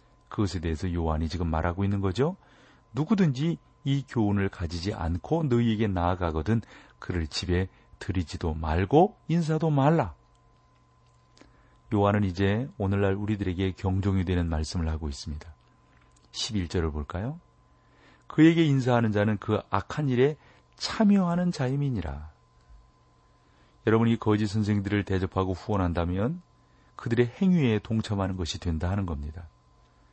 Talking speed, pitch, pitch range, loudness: 295 characters per minute, 95 Hz, 80-115 Hz, -27 LUFS